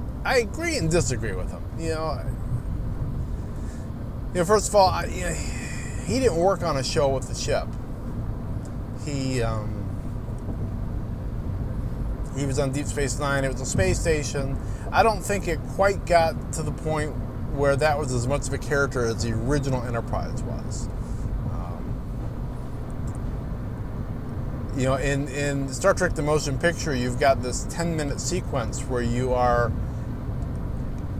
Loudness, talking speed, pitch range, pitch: -26 LUFS, 155 wpm, 115-140 Hz, 120 Hz